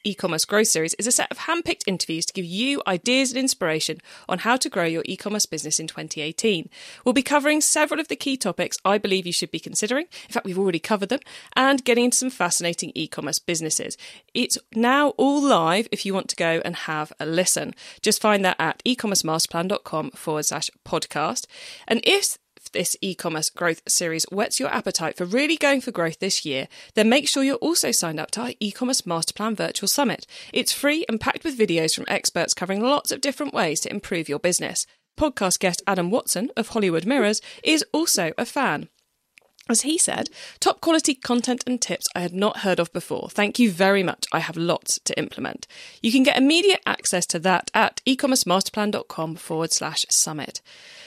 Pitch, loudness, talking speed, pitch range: 205 Hz, -22 LUFS, 195 wpm, 170-255 Hz